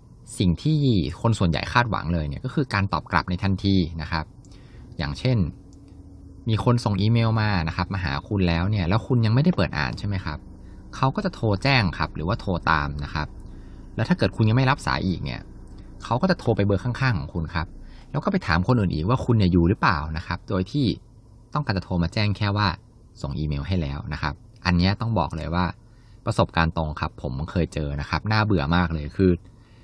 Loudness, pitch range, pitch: -24 LUFS, 85-115 Hz, 95 Hz